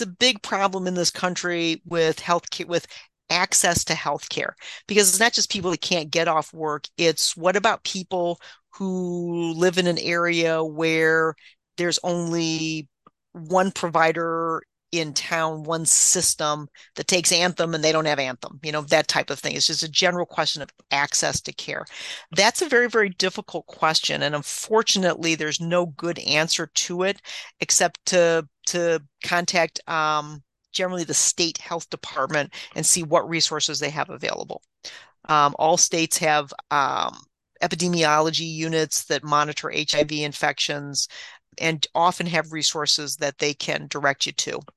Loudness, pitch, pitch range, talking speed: -22 LUFS, 165 Hz, 155-175 Hz, 155 wpm